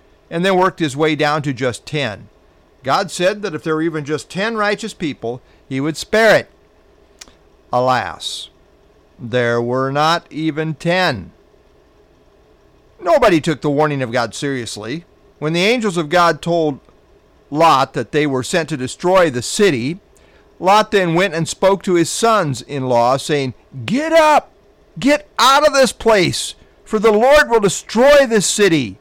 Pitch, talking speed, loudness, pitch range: 160 Hz, 160 wpm, -16 LUFS, 135-200 Hz